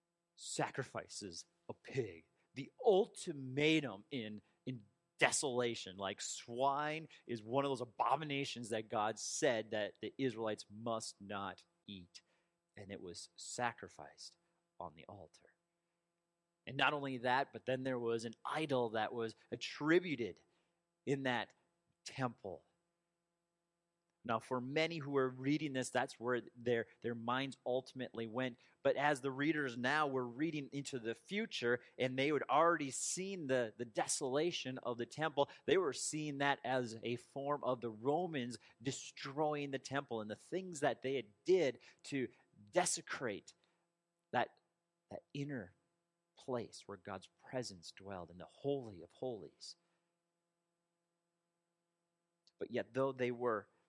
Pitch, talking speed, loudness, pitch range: 135 Hz, 135 wpm, -40 LUFS, 120-170 Hz